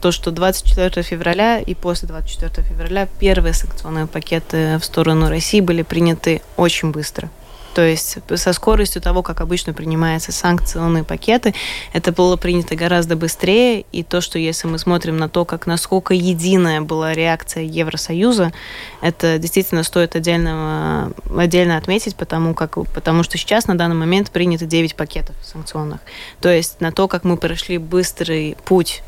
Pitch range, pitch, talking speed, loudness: 160-180 Hz, 170 Hz, 155 wpm, -17 LUFS